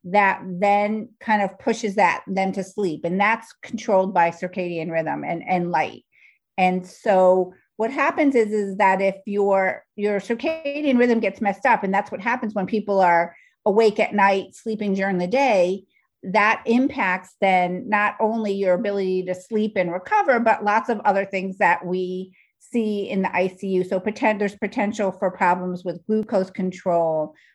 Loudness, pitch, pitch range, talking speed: -21 LUFS, 195 Hz, 185-215 Hz, 170 wpm